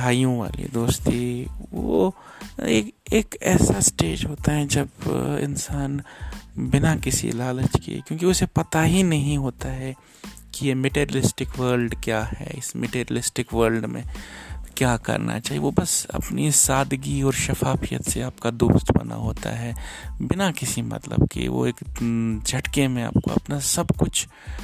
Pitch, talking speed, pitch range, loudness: 130 Hz, 145 wpm, 115-140 Hz, -23 LUFS